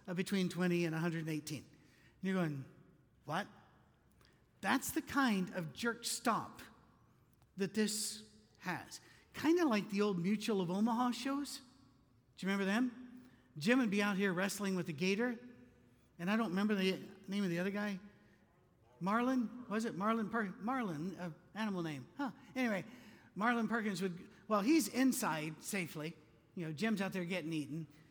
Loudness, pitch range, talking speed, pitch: -37 LUFS, 170-225 Hz, 160 wpm, 195 Hz